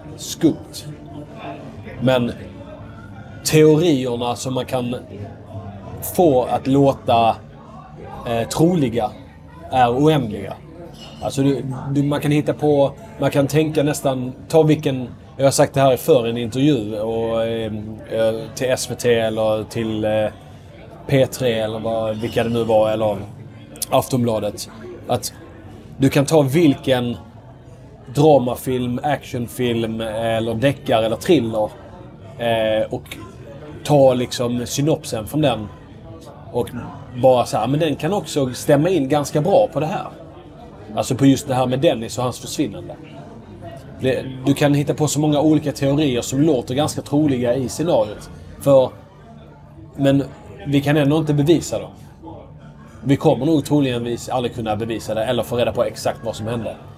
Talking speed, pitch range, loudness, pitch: 140 wpm, 110-140 Hz, -19 LUFS, 125 Hz